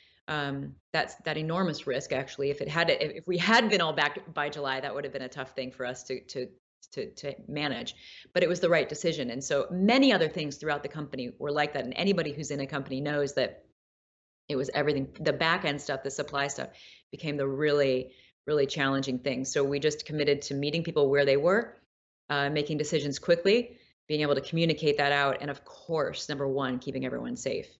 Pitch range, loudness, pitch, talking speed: 135-155 Hz, -29 LUFS, 145 Hz, 220 wpm